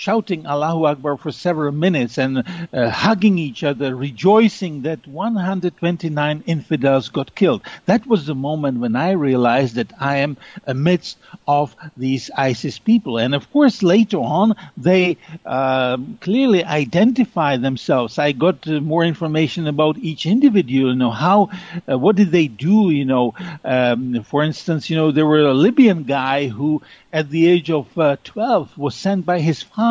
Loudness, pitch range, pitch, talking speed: -18 LUFS, 140-185 Hz, 155 Hz, 165 wpm